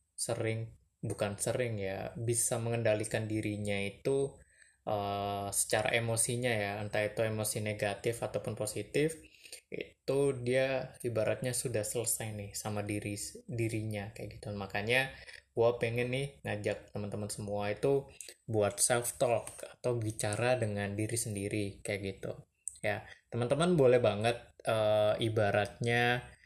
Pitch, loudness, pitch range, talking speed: 110 Hz, -33 LUFS, 105-120 Hz, 120 wpm